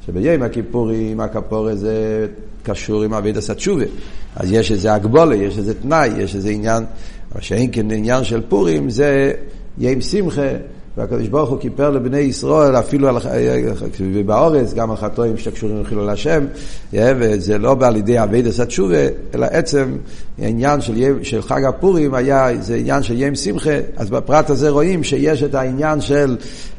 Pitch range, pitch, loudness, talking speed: 110-140 Hz, 120 Hz, -17 LUFS, 160 wpm